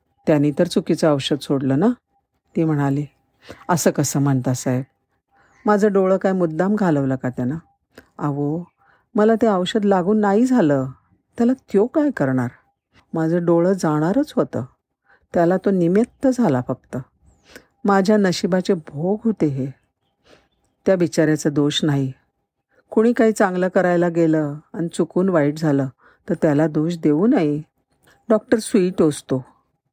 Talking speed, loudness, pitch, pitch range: 130 wpm, -19 LUFS, 165 Hz, 140-200 Hz